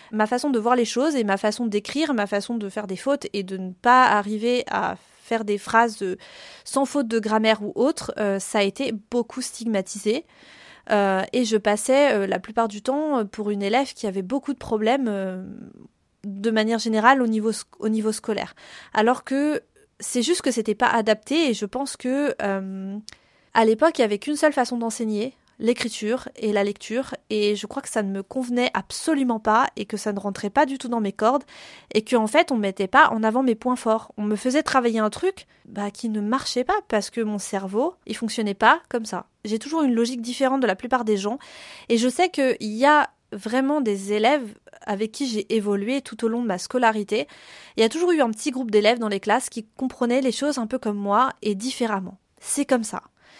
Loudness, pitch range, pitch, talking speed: -23 LUFS, 210-260 Hz, 230 Hz, 225 wpm